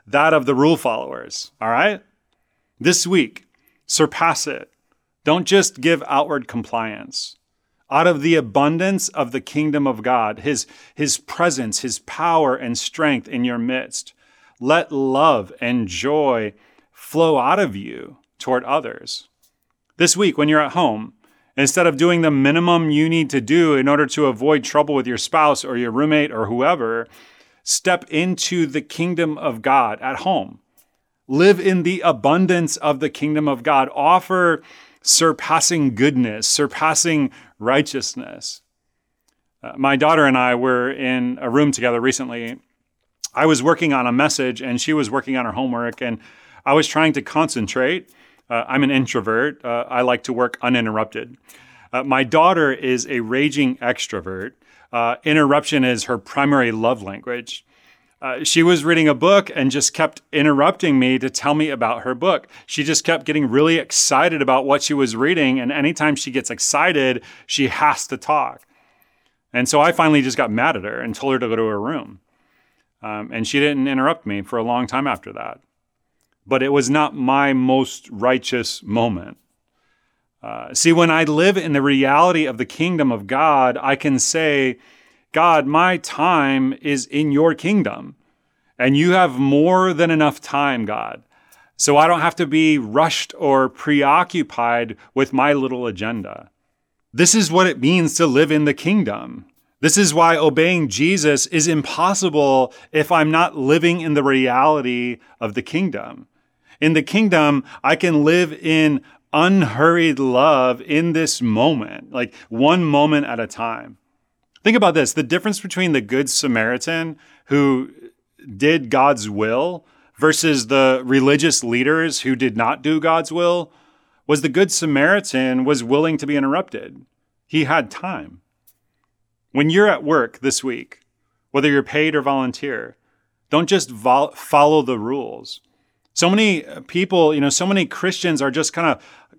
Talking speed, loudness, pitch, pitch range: 160 wpm, -17 LUFS, 145 Hz, 130-160 Hz